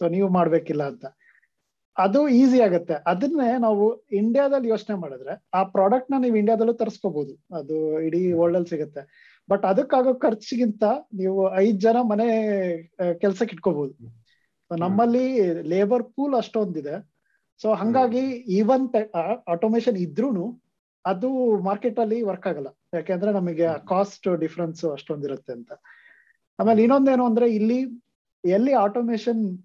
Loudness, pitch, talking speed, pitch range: -23 LUFS, 205 Hz, 115 wpm, 175-240 Hz